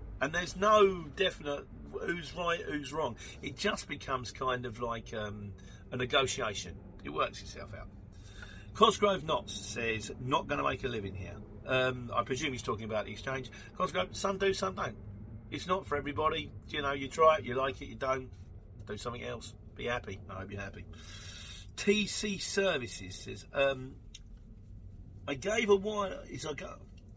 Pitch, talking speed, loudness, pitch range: 115 Hz, 170 wpm, -33 LUFS, 100-145 Hz